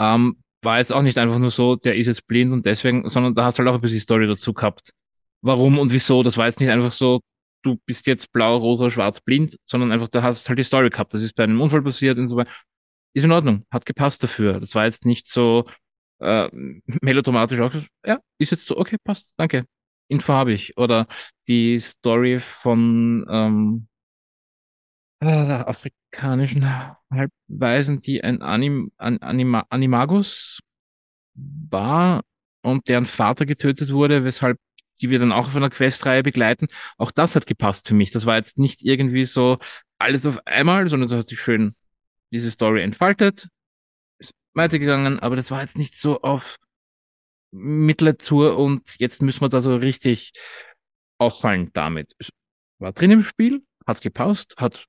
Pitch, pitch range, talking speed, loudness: 125 Hz, 115-140 Hz, 180 wpm, -20 LUFS